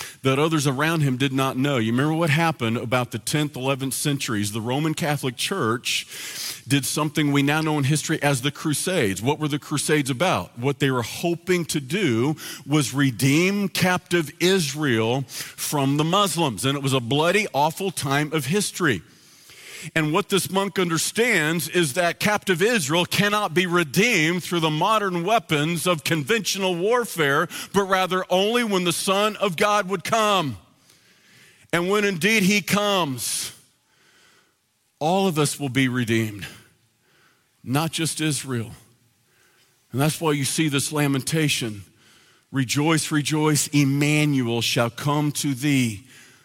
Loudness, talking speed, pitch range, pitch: -22 LUFS, 145 wpm, 135-180 Hz, 150 Hz